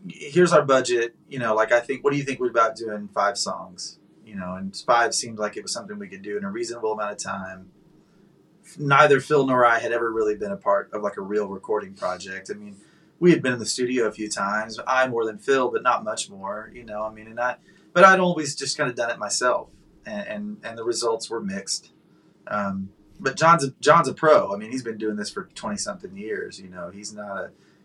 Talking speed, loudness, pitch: 245 wpm, -23 LUFS, 135 Hz